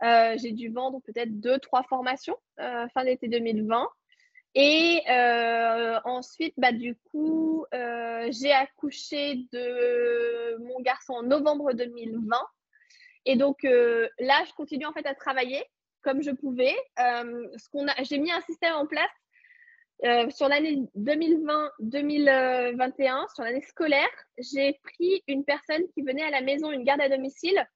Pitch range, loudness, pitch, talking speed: 245-300 Hz, -26 LUFS, 270 Hz, 155 wpm